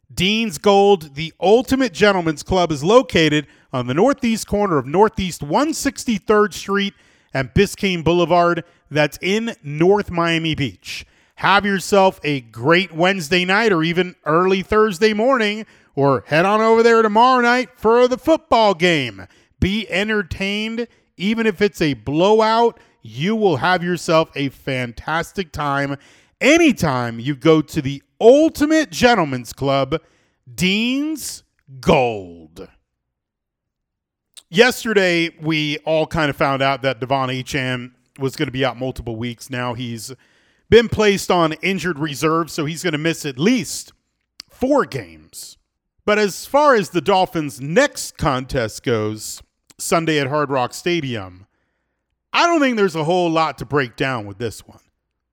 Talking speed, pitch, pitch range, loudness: 140 wpm, 170 Hz, 140-210 Hz, -18 LUFS